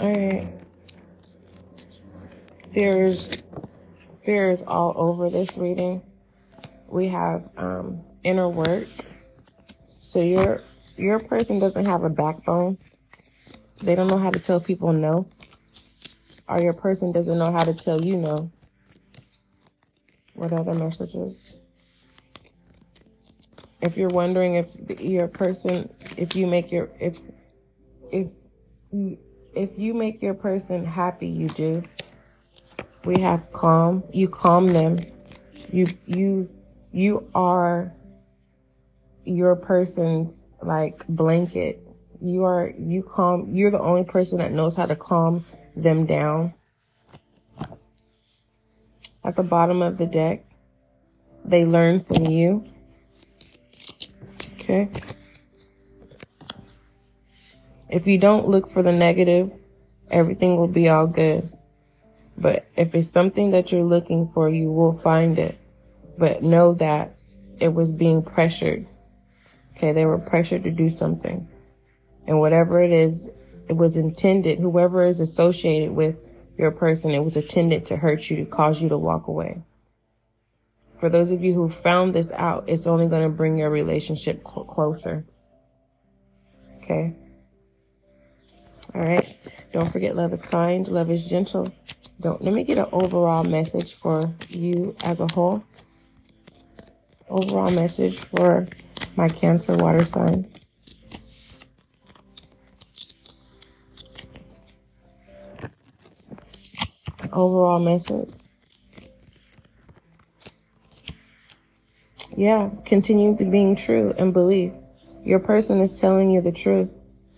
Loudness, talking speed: -21 LUFS, 115 wpm